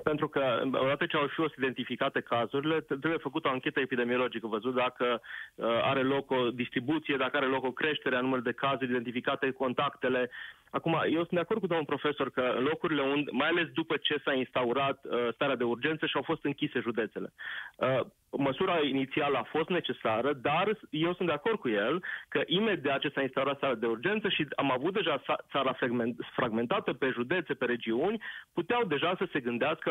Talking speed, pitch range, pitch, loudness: 180 wpm, 125-155 Hz, 140 Hz, -31 LUFS